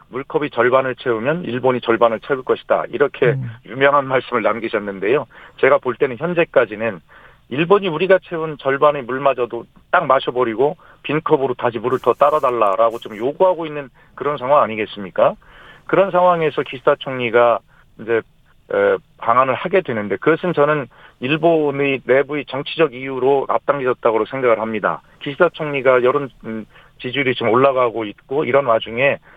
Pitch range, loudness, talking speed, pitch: 120-155 Hz, -18 LUFS, 355 characters per minute, 135 Hz